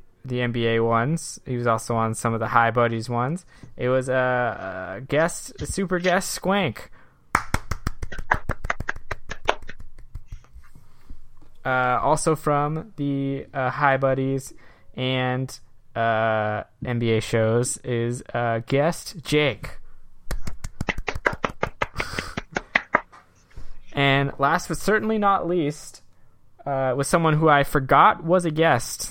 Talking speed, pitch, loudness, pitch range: 105 wpm, 130 Hz, -23 LUFS, 115-150 Hz